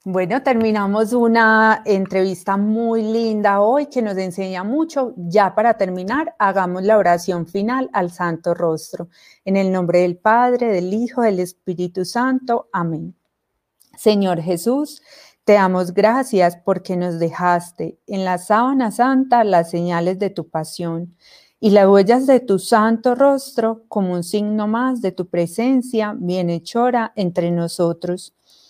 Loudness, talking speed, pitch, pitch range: -18 LUFS, 140 wpm, 200 Hz, 180-230 Hz